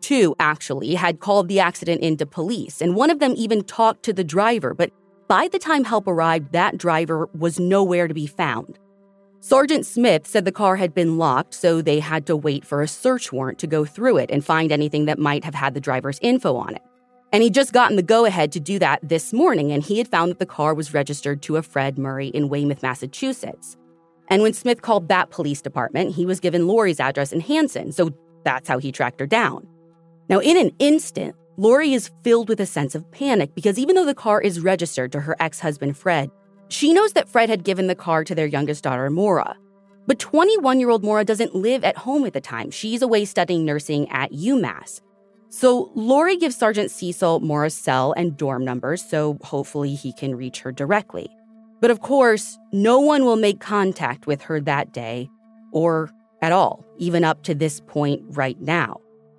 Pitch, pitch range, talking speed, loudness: 175 Hz, 150-220 Hz, 205 wpm, -20 LUFS